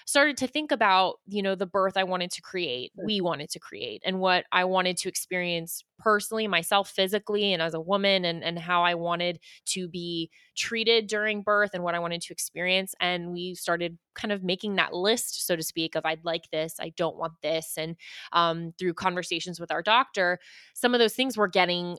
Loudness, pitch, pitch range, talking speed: -27 LUFS, 180 Hz, 170-200 Hz, 210 wpm